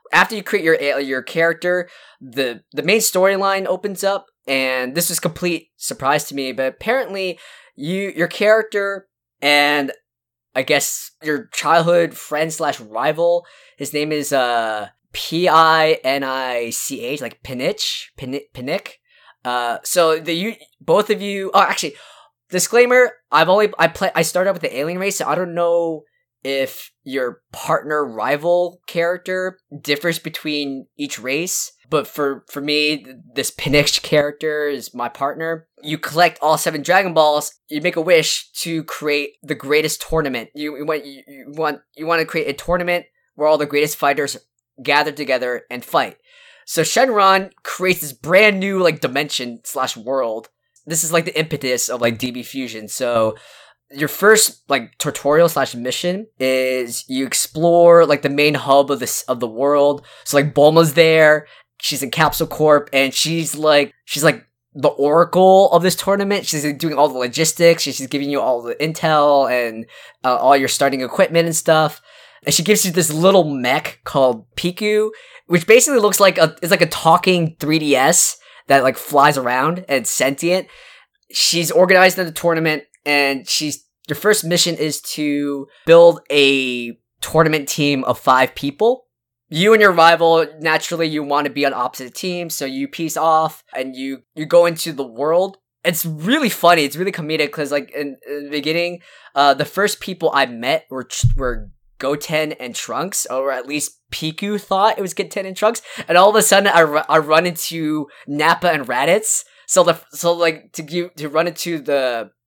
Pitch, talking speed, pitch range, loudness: 155 Hz, 170 wpm, 140-175 Hz, -17 LUFS